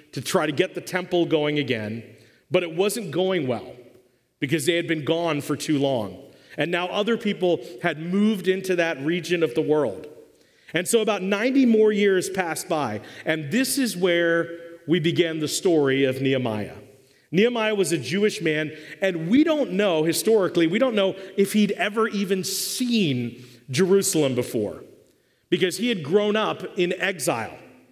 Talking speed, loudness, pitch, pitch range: 170 wpm, -23 LUFS, 175 Hz, 155-200 Hz